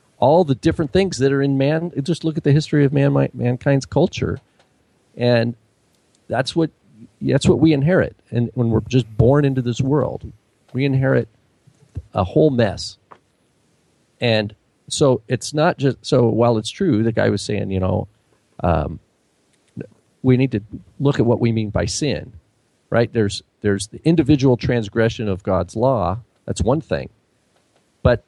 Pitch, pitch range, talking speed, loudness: 125 Hz, 110-140 Hz, 160 wpm, -19 LUFS